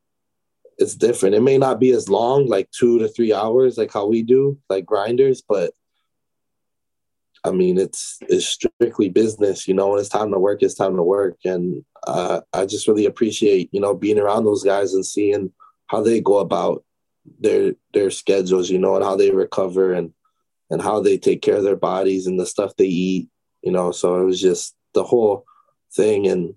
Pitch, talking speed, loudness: 130 Hz, 200 wpm, -19 LUFS